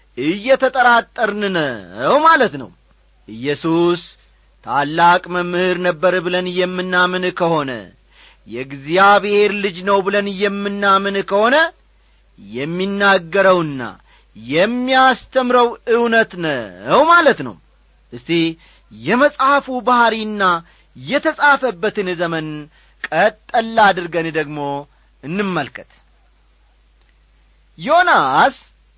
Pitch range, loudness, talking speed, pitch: 165-230 Hz, -16 LUFS, 70 wpm, 185 Hz